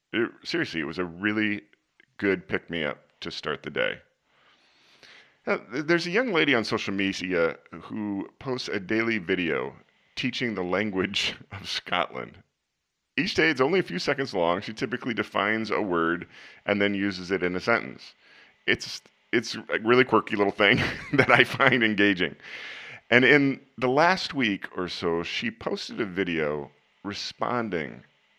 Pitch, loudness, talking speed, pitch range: 100 Hz, -26 LUFS, 160 wpm, 90-120 Hz